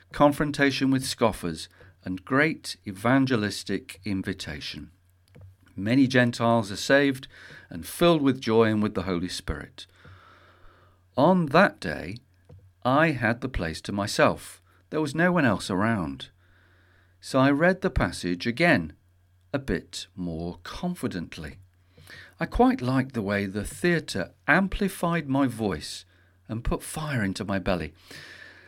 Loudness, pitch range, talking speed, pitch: -25 LUFS, 90-135 Hz, 130 wpm, 100 Hz